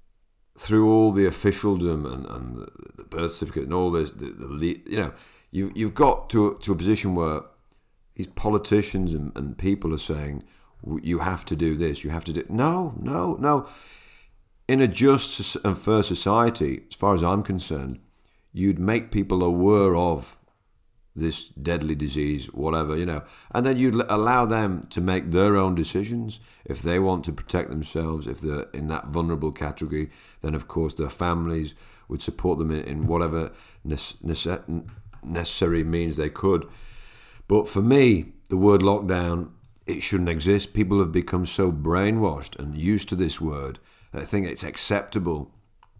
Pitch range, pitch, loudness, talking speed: 80-105 Hz, 90 Hz, -24 LUFS, 170 wpm